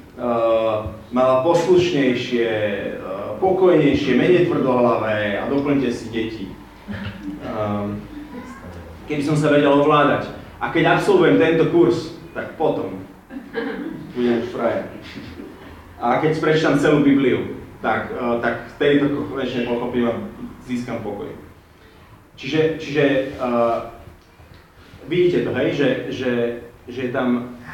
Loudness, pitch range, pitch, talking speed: -19 LUFS, 110-150 Hz, 125 Hz, 115 wpm